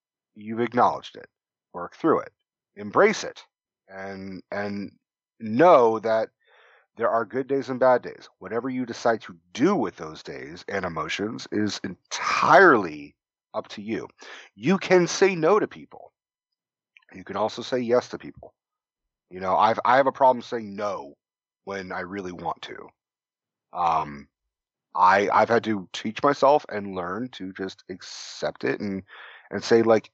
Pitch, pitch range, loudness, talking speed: 110 Hz, 95-125 Hz, -23 LUFS, 155 wpm